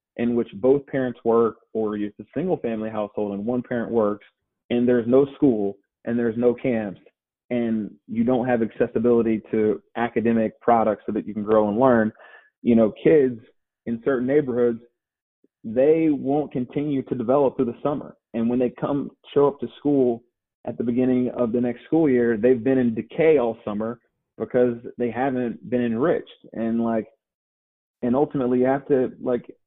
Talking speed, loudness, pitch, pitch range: 175 wpm, -23 LUFS, 120 Hz, 115-130 Hz